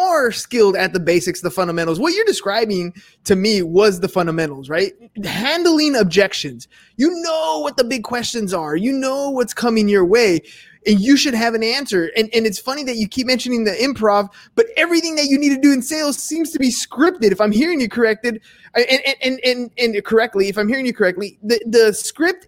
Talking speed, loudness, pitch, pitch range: 205 wpm, -17 LUFS, 230 Hz, 205-275 Hz